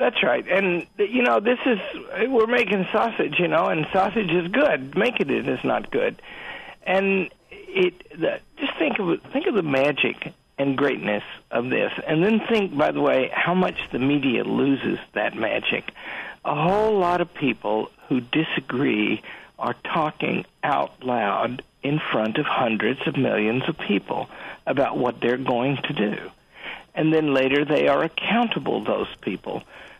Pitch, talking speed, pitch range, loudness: 175 Hz, 170 wpm, 140-220 Hz, -23 LUFS